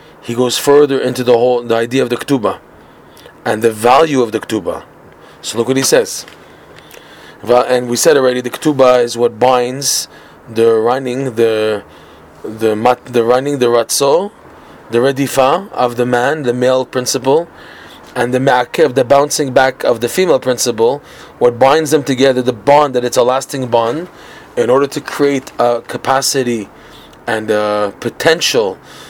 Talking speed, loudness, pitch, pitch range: 165 wpm, -13 LUFS, 125 Hz, 120-135 Hz